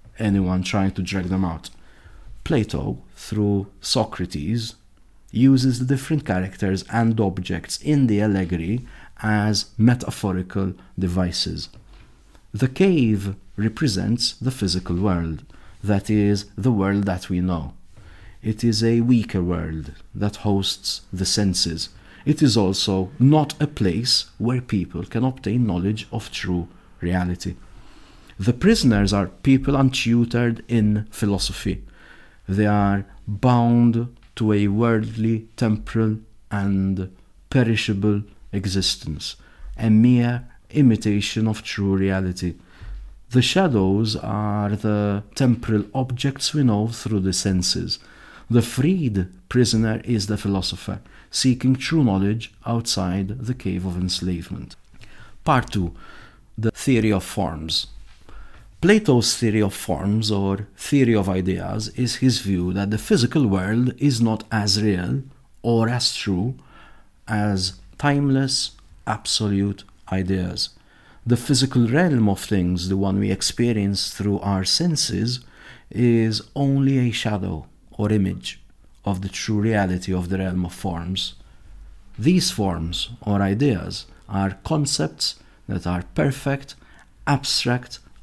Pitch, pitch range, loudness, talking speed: 105 Hz, 95-120 Hz, -22 LUFS, 120 wpm